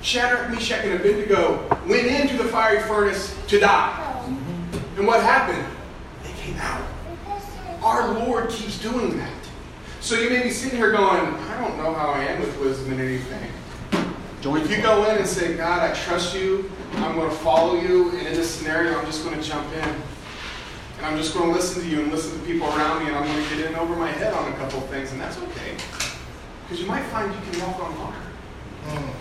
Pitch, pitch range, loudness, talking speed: 170 Hz, 150-205 Hz, -23 LUFS, 215 wpm